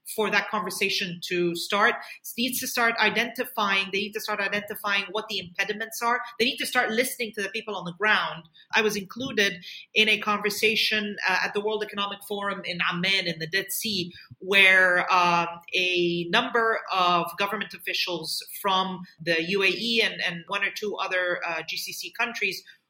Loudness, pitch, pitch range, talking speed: -24 LUFS, 200 Hz, 180-220 Hz, 175 wpm